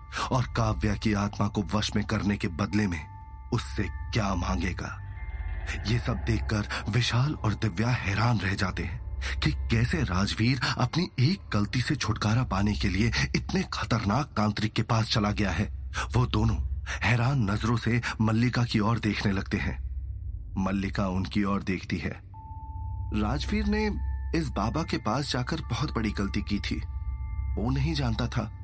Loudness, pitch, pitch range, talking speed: -28 LUFS, 105 Hz, 95-115 Hz, 155 wpm